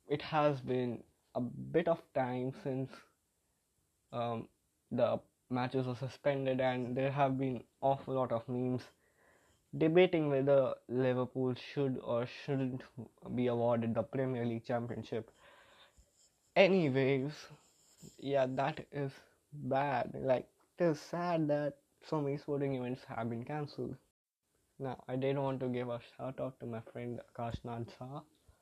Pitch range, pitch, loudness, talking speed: 120-140 Hz, 130 Hz, -36 LUFS, 130 wpm